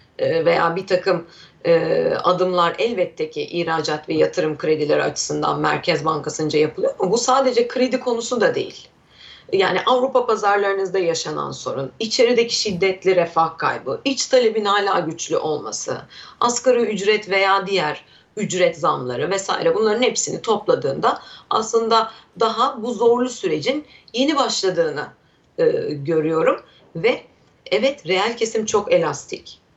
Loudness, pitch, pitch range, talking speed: -20 LUFS, 220 Hz, 175-265 Hz, 125 wpm